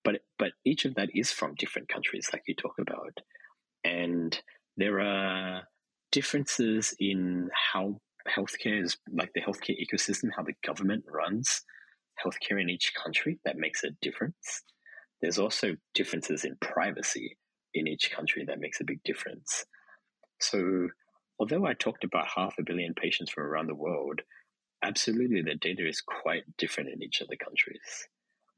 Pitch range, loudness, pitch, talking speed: 90-100 Hz, -31 LUFS, 95 Hz, 155 wpm